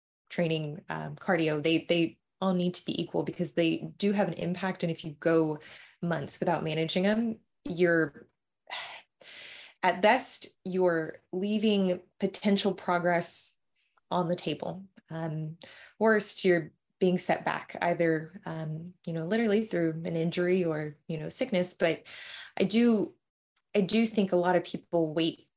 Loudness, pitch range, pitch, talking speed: -29 LUFS, 165-195 Hz, 175 Hz, 150 wpm